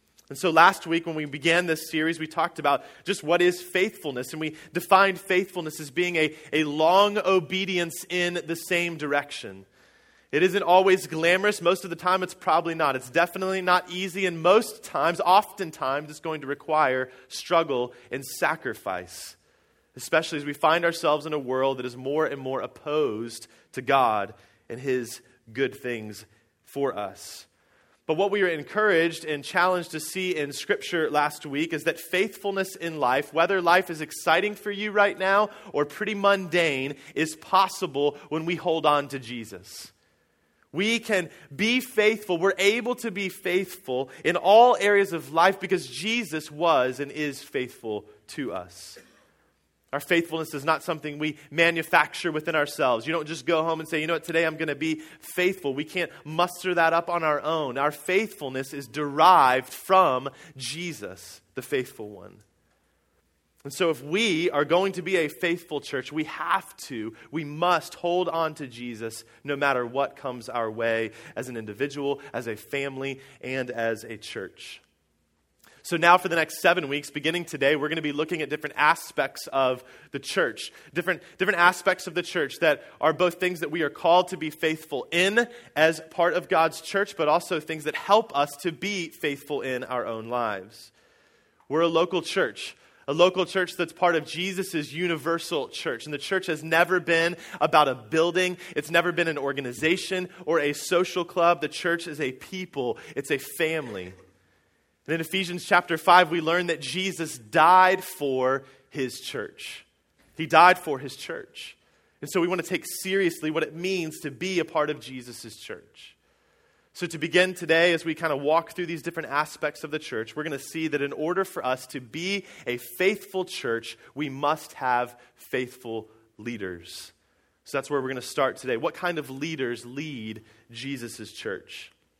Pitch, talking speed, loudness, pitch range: 160 Hz, 180 wpm, -25 LUFS, 140-180 Hz